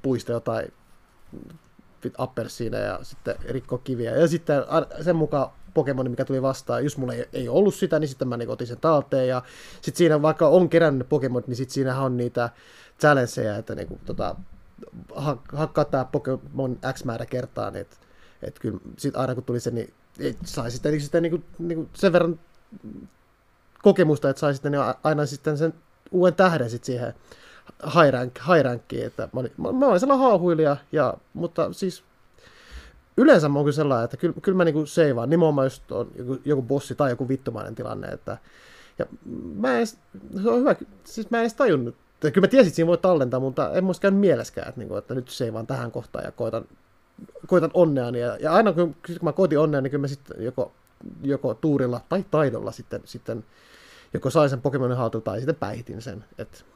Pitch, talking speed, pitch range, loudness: 145 Hz, 185 wpm, 130-170 Hz, -24 LUFS